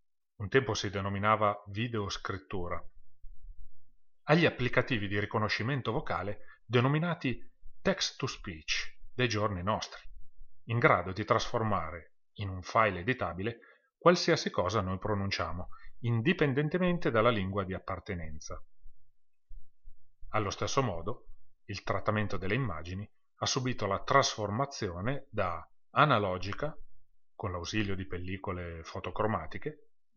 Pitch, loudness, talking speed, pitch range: 110 Hz, -32 LUFS, 105 wpm, 100-125 Hz